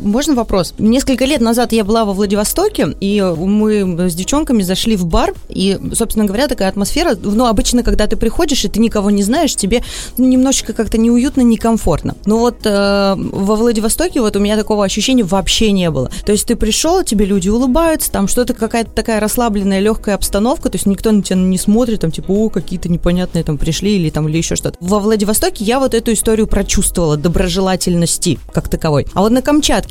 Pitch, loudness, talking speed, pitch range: 215 Hz, -14 LUFS, 195 wpm, 195-235 Hz